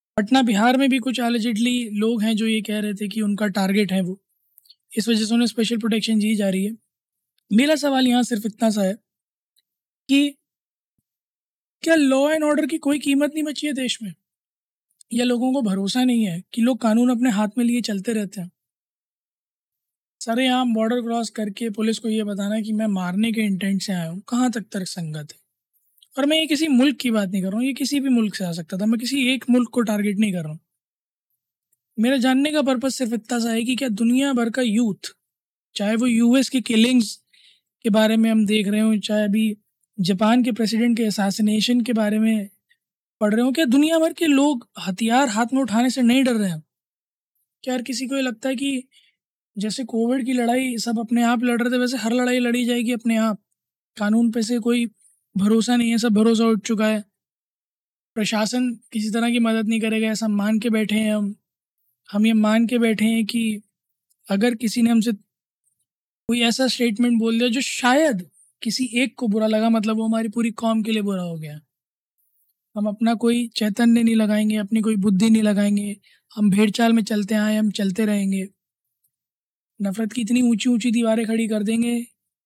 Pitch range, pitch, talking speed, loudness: 210-245 Hz, 225 Hz, 205 wpm, -21 LUFS